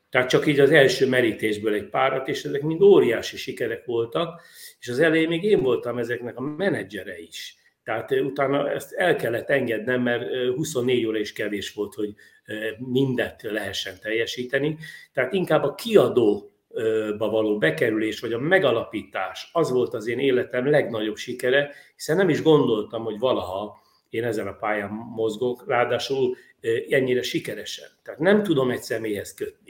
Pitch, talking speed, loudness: 130 Hz, 155 wpm, -23 LUFS